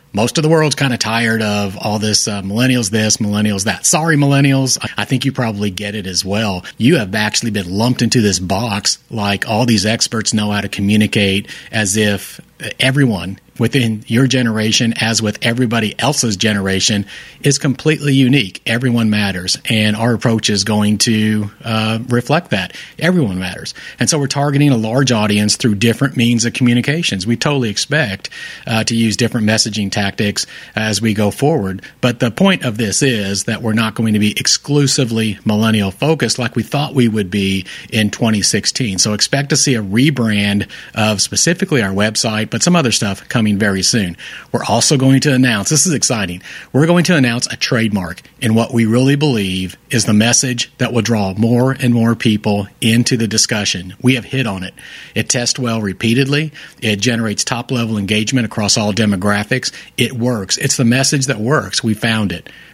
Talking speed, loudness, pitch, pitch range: 185 wpm, -14 LUFS, 115 Hz, 105-130 Hz